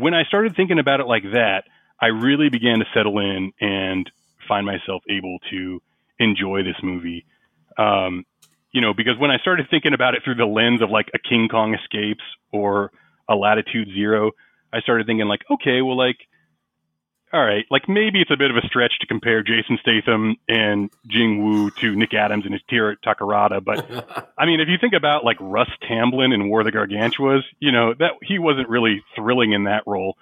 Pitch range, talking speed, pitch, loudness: 105-130 Hz, 205 wpm, 110 Hz, -19 LUFS